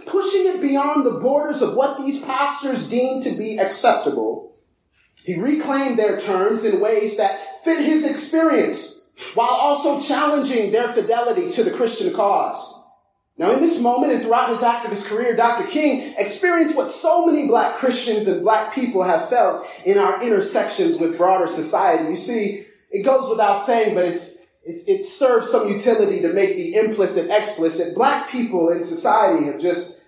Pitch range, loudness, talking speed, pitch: 215-330 Hz, -19 LUFS, 170 wpm, 260 Hz